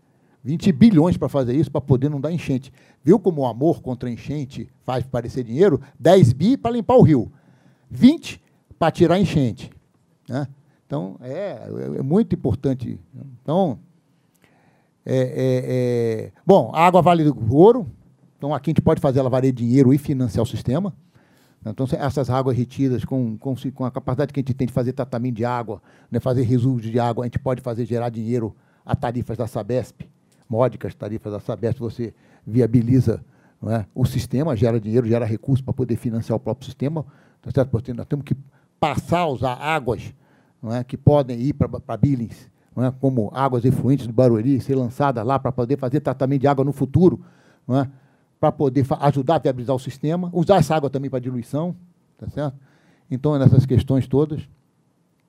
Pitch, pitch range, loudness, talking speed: 135 Hz, 125-150 Hz, -20 LUFS, 180 wpm